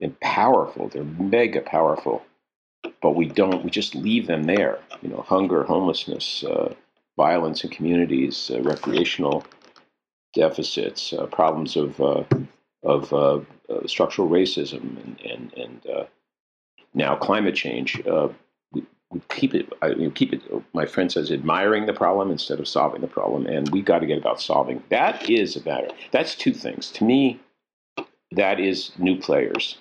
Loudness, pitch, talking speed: -23 LUFS, 135 Hz, 160 wpm